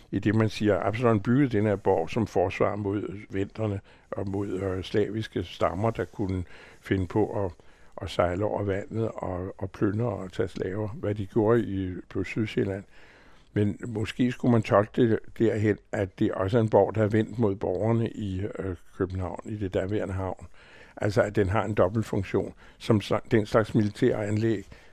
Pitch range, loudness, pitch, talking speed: 95-110 Hz, -27 LUFS, 105 Hz, 185 wpm